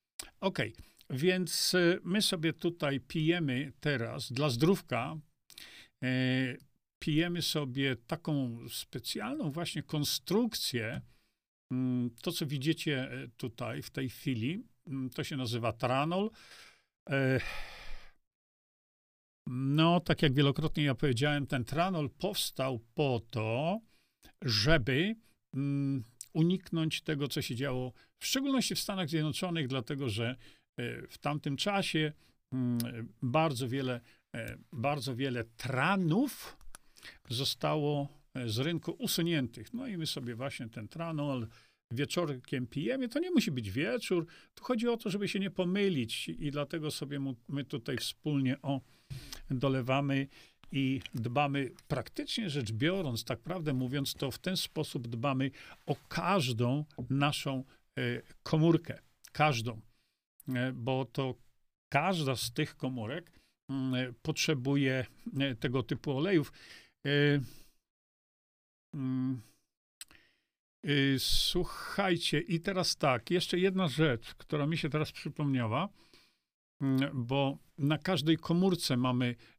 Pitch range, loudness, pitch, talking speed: 130-165 Hz, -33 LUFS, 140 Hz, 105 wpm